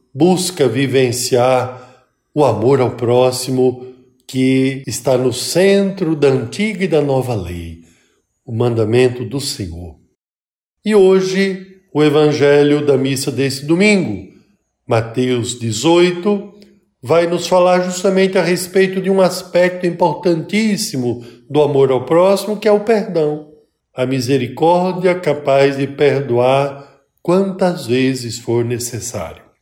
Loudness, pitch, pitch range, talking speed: -15 LUFS, 140 Hz, 125-180 Hz, 115 wpm